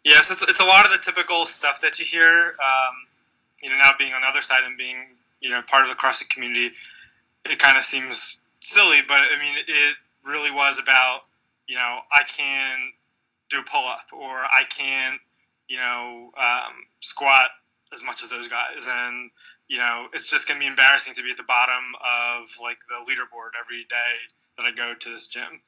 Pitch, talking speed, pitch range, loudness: 130 Hz, 210 wpm, 120-140 Hz, -18 LUFS